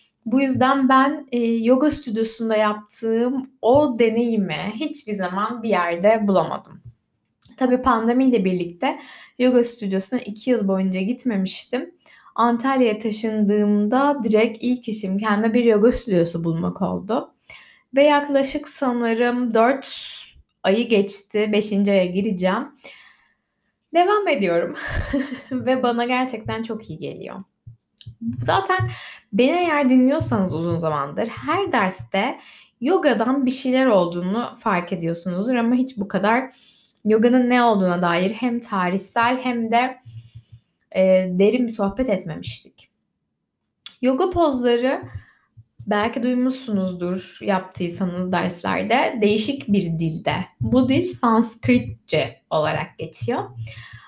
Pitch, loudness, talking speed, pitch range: 225 Hz, -20 LUFS, 105 wpm, 185-255 Hz